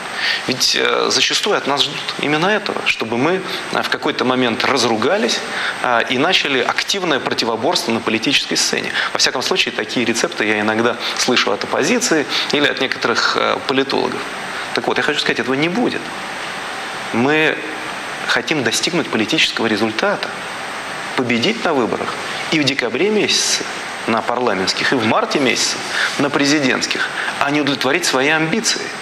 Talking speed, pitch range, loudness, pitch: 140 wpm, 115-145 Hz, -16 LUFS, 130 Hz